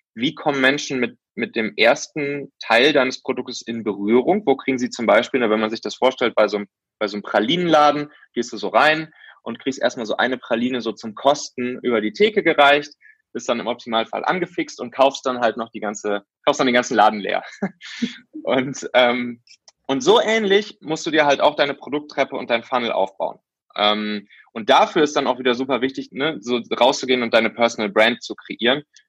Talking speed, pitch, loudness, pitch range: 200 wpm, 130 Hz, -20 LUFS, 115-145 Hz